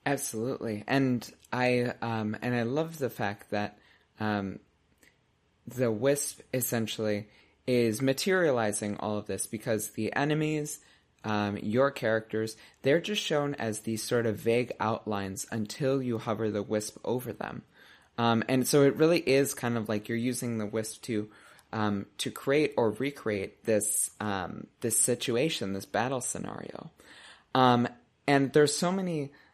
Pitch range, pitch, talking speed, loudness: 105-135 Hz, 115 Hz, 145 wpm, -30 LUFS